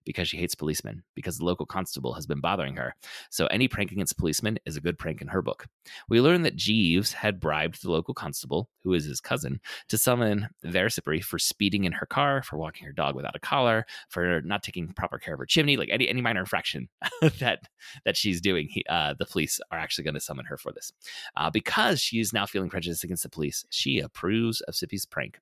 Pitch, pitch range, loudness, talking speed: 105 Hz, 90-125 Hz, -27 LUFS, 225 wpm